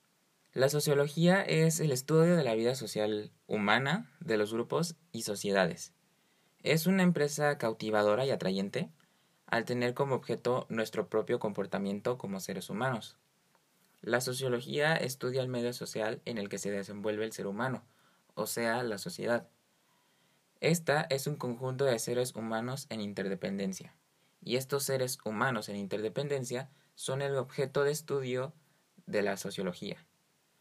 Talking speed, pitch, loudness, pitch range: 140 wpm, 125 Hz, -33 LUFS, 110-145 Hz